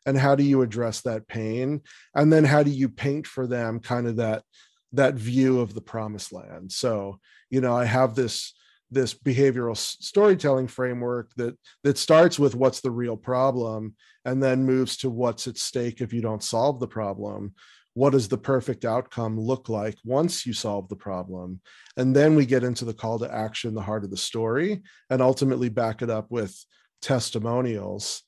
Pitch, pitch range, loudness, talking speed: 125 Hz, 110-135 Hz, -24 LUFS, 185 wpm